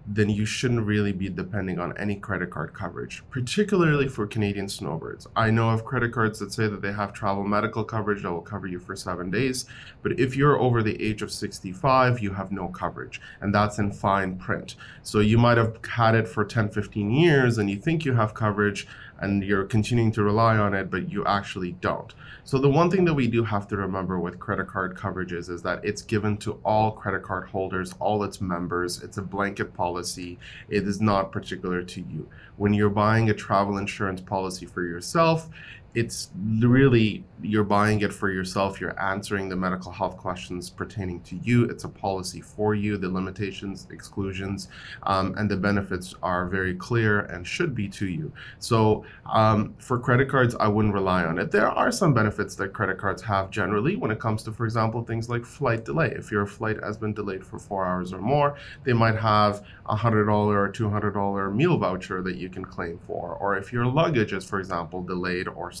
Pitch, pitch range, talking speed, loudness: 105 Hz, 95-110 Hz, 205 wpm, -25 LUFS